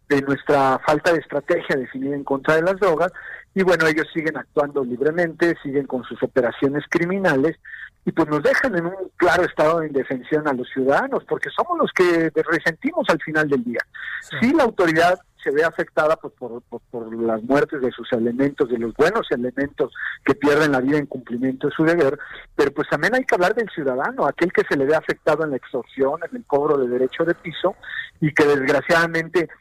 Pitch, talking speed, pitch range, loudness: 155 Hz, 205 wpm, 135-170 Hz, -20 LUFS